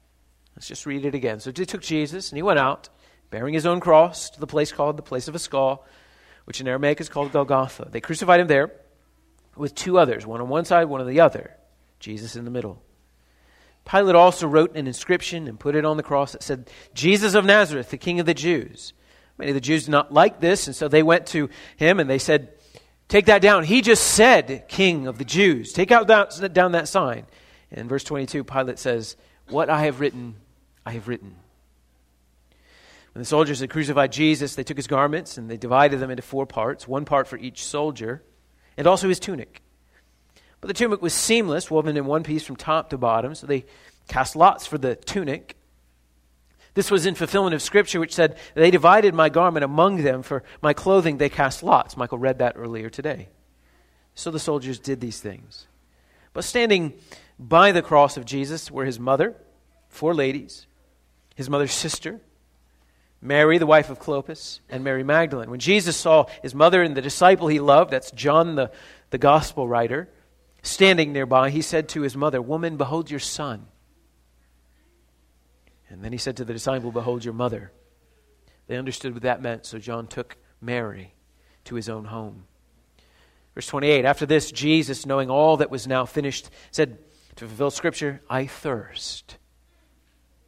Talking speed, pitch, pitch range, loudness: 190 wpm, 135 Hz, 110-155 Hz, -21 LUFS